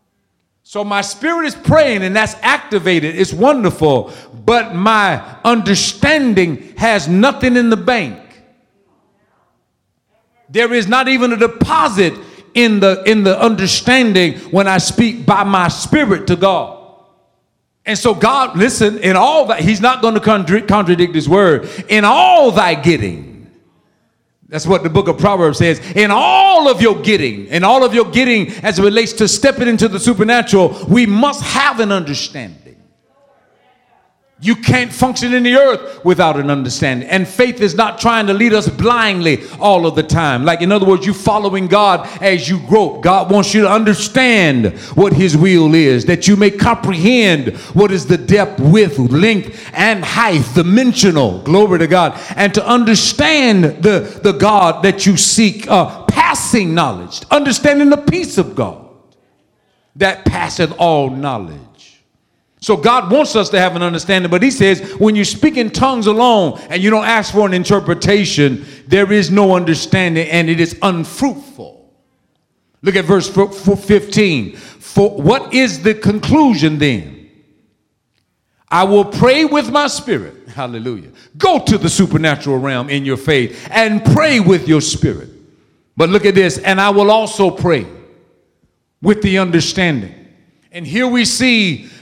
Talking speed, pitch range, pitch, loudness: 160 wpm, 170-225 Hz, 200 Hz, -12 LUFS